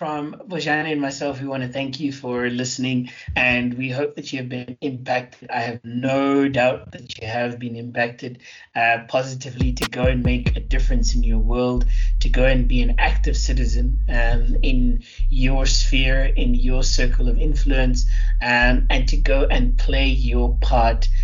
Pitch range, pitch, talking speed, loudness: 120-135 Hz, 125 Hz, 180 wpm, -21 LUFS